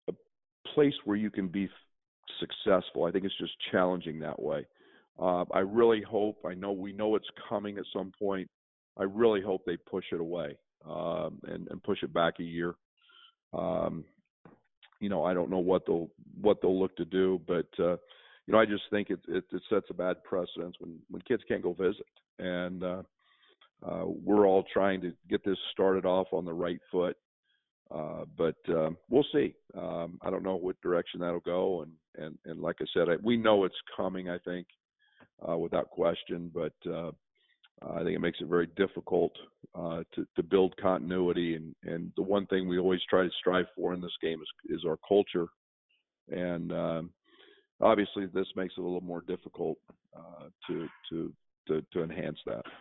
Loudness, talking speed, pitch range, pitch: -32 LUFS, 190 wpm, 85-100 Hz, 95 Hz